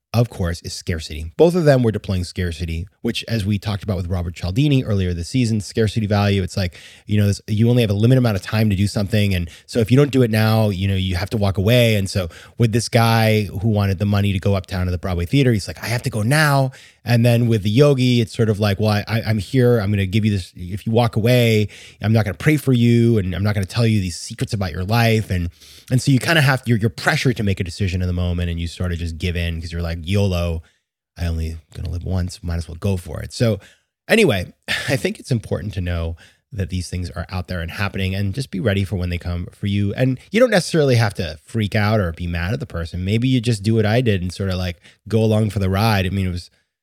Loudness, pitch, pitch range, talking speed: -19 LUFS, 105 Hz, 90-115 Hz, 280 wpm